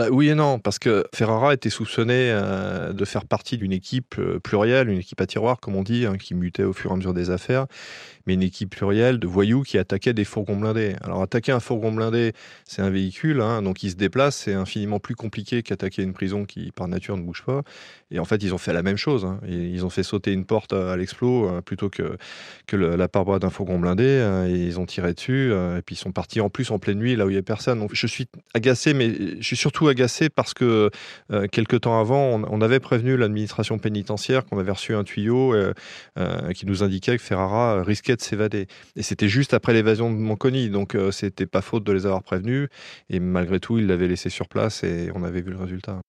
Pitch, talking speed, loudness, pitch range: 105 Hz, 240 wpm, -23 LUFS, 95-120 Hz